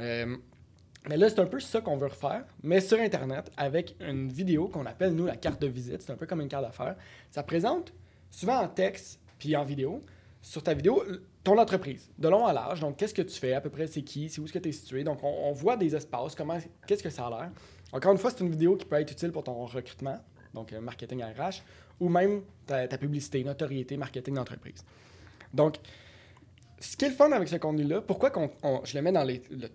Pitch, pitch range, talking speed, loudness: 145 Hz, 125-170 Hz, 240 wpm, -30 LUFS